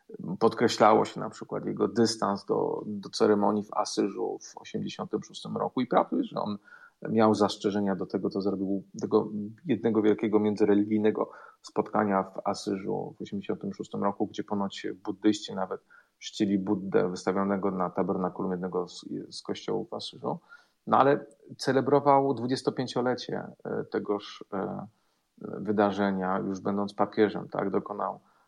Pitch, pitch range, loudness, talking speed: 105 Hz, 100-110 Hz, -29 LUFS, 130 wpm